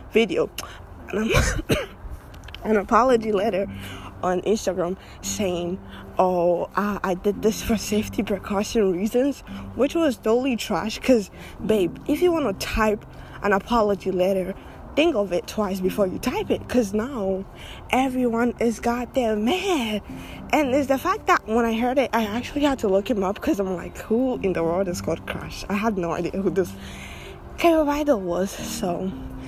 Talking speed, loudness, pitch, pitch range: 165 wpm, -23 LUFS, 210 Hz, 185-245 Hz